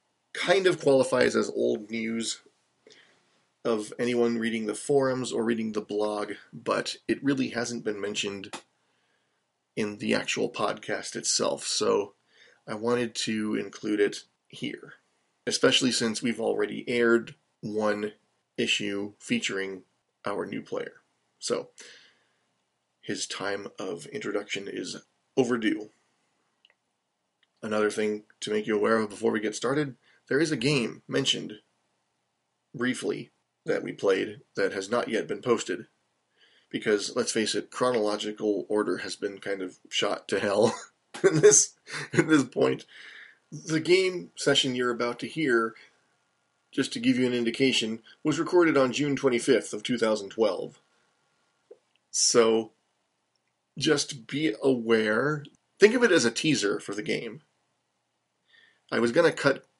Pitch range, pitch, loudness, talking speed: 105-135 Hz, 115 Hz, -27 LUFS, 135 wpm